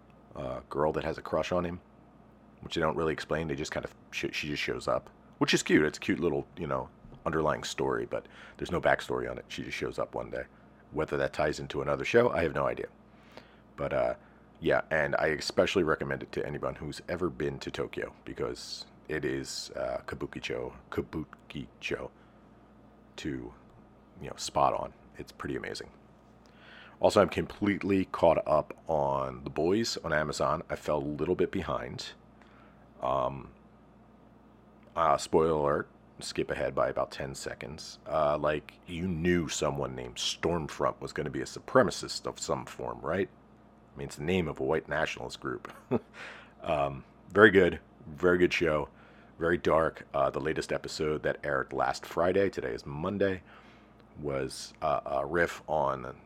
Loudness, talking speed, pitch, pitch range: -31 LUFS, 175 wpm, 75 Hz, 70-90 Hz